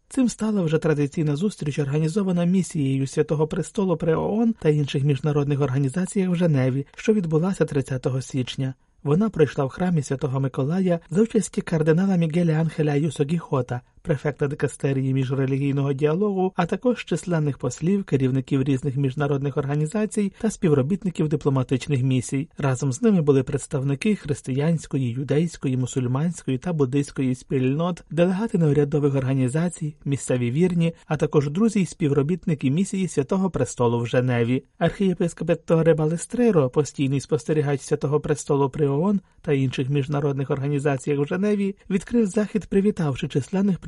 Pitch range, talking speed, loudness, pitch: 140-180 Hz, 130 wpm, -23 LUFS, 150 Hz